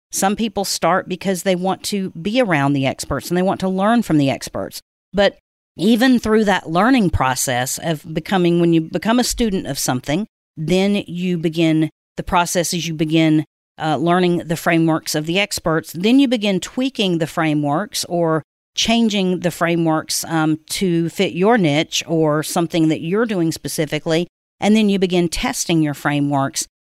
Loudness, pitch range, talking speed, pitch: -18 LUFS, 155-195 Hz, 170 wpm, 170 Hz